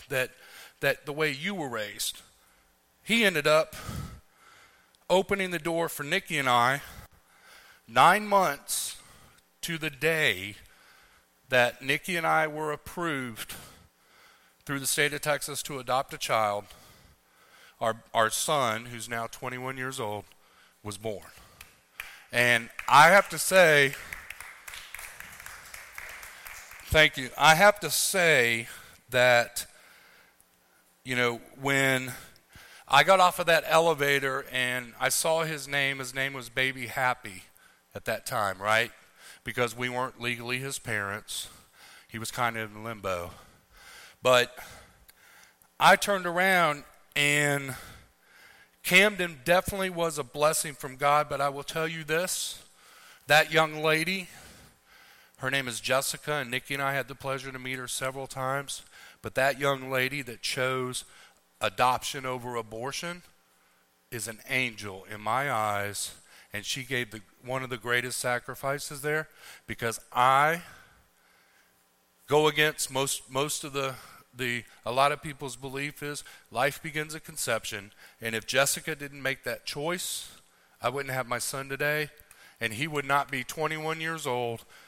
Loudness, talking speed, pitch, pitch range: -27 LUFS, 140 wpm, 135 Hz, 120-150 Hz